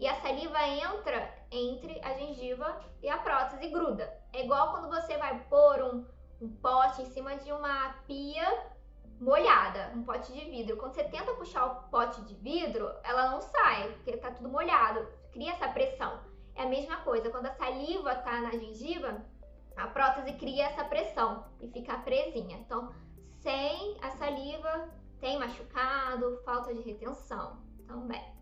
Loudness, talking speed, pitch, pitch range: -32 LUFS, 165 wpm, 265 Hz, 245-295 Hz